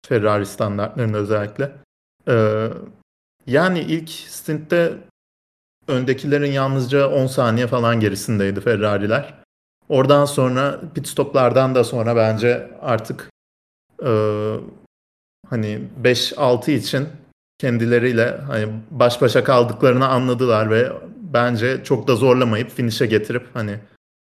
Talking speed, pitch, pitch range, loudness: 100 wpm, 120 Hz, 110-135 Hz, -19 LUFS